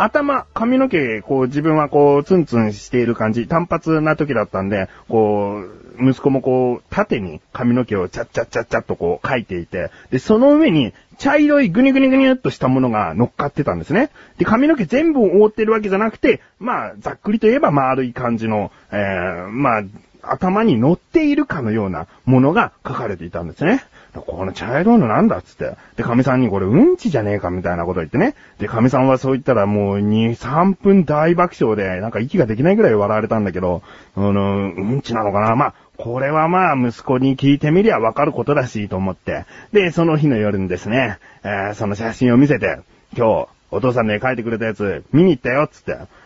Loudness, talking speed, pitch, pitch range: -17 LUFS, 405 characters per minute, 130 Hz, 105-170 Hz